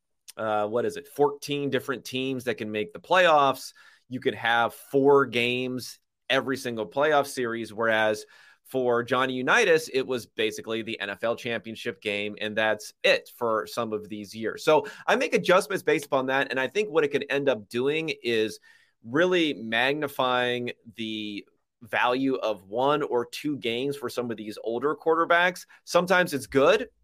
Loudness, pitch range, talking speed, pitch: -26 LUFS, 110-145 Hz, 165 wpm, 125 Hz